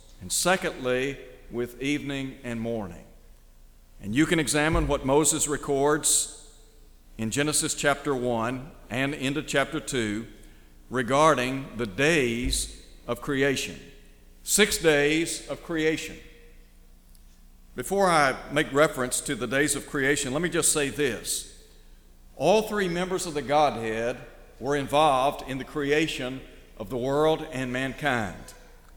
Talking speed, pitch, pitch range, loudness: 125 wpm, 135 Hz, 115-150 Hz, -25 LUFS